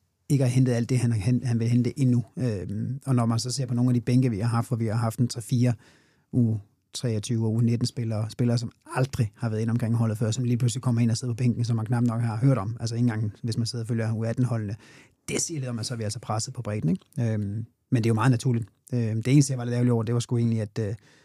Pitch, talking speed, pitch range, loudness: 120 Hz, 280 wpm, 115-125 Hz, -26 LUFS